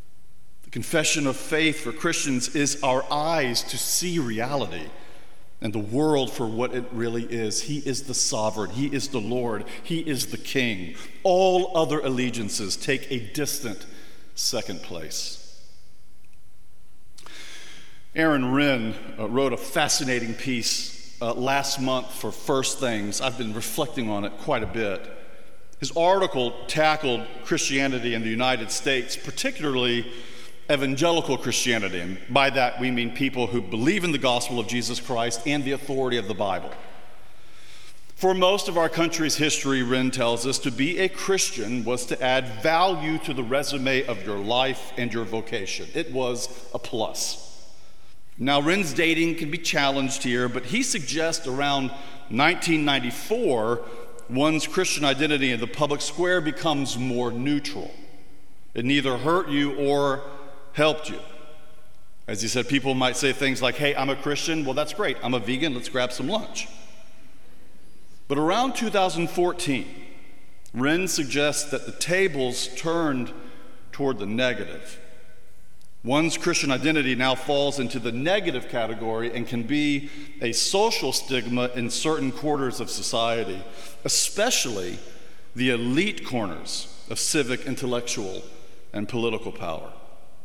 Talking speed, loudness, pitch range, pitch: 140 wpm, -25 LUFS, 120-150 Hz, 135 Hz